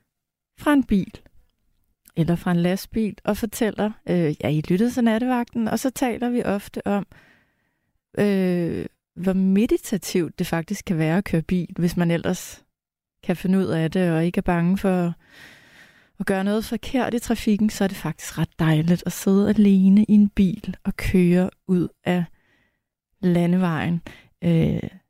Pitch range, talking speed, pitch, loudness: 175-210 Hz, 165 wpm, 190 Hz, -22 LUFS